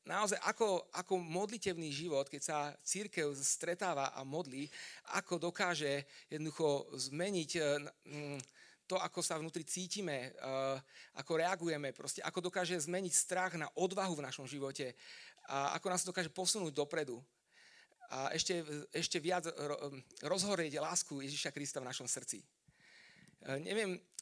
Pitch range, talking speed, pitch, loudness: 145-185 Hz, 125 wpm, 165 Hz, -39 LUFS